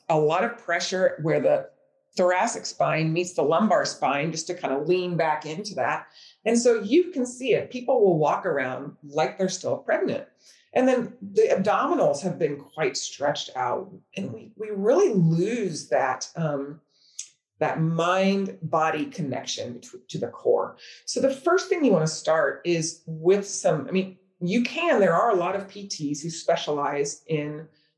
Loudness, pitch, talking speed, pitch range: -25 LUFS, 180 Hz, 175 wpm, 160-225 Hz